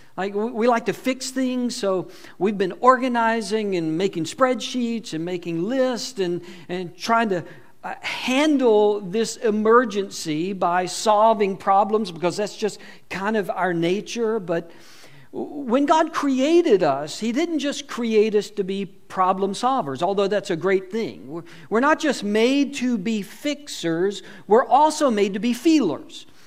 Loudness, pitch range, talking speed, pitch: -22 LUFS, 185-250 Hz, 145 wpm, 210 Hz